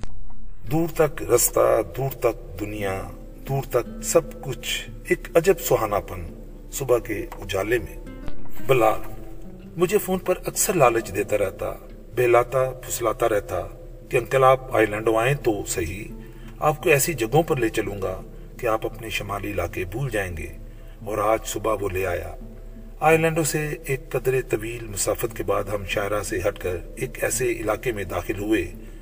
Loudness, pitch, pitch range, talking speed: -23 LUFS, 115 Hz, 110-155 Hz, 160 wpm